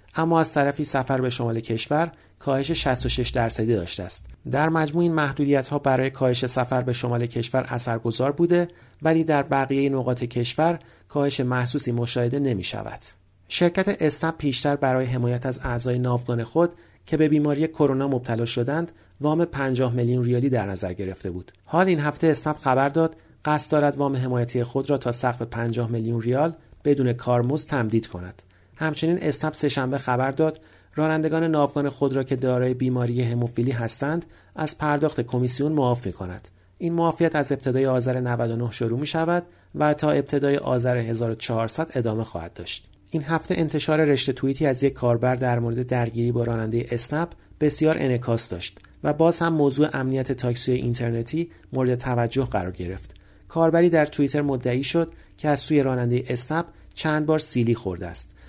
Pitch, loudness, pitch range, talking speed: 130 Hz, -24 LUFS, 120-150 Hz, 160 wpm